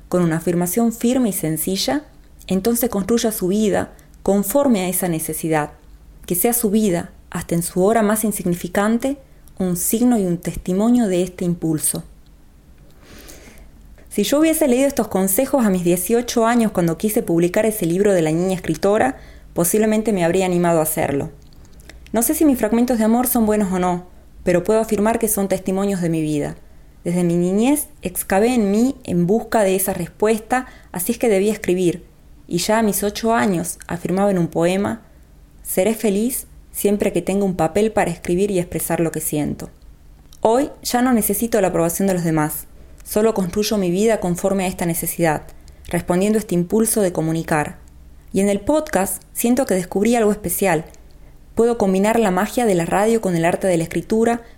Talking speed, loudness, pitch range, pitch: 180 wpm, -19 LUFS, 170-220 Hz, 190 Hz